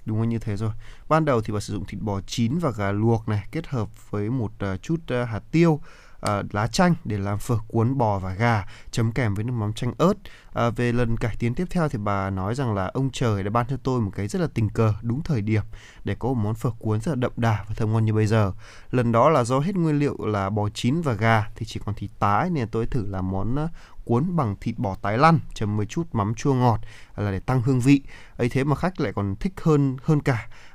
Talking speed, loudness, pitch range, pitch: 260 wpm, -24 LUFS, 105-130 Hz, 115 Hz